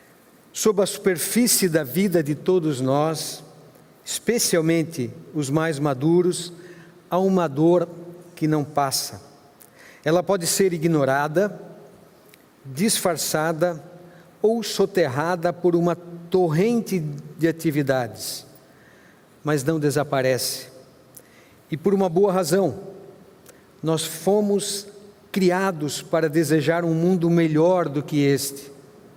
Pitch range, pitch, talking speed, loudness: 150-190 Hz, 170 Hz, 100 wpm, -22 LUFS